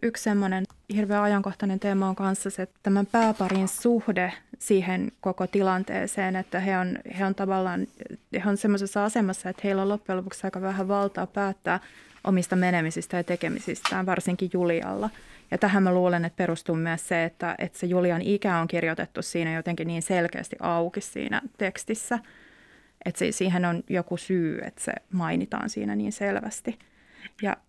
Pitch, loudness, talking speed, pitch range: 190 Hz, -27 LUFS, 165 wpm, 175-200 Hz